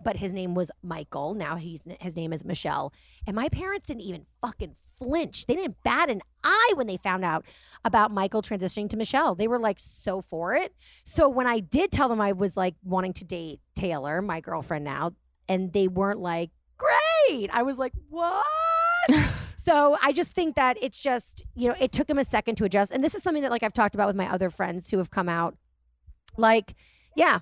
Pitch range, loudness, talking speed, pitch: 180-265 Hz, -26 LUFS, 215 wpm, 205 Hz